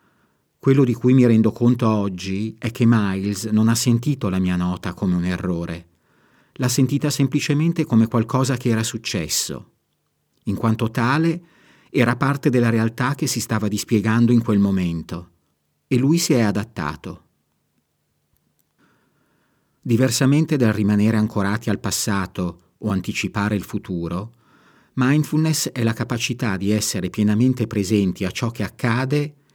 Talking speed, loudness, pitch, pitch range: 140 wpm, -20 LUFS, 110 Hz, 100-125 Hz